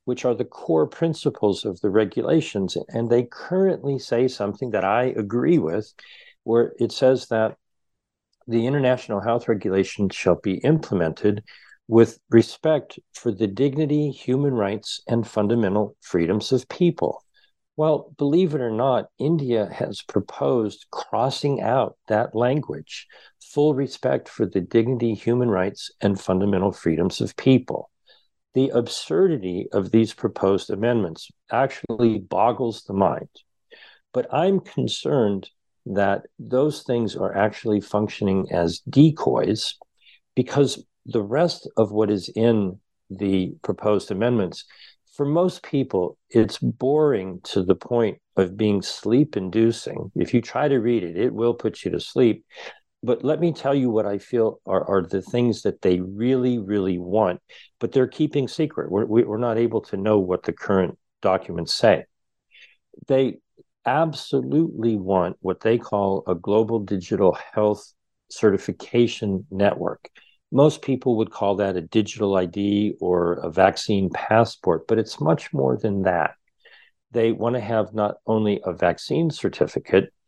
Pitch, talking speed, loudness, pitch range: 115 Hz, 140 wpm, -22 LUFS, 100-130 Hz